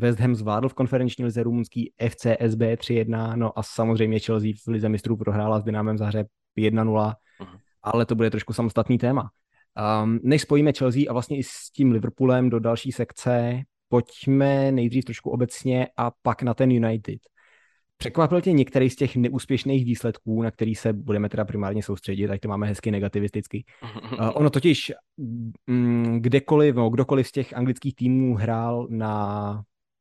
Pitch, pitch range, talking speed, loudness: 115 Hz, 110-130 Hz, 165 wpm, -24 LUFS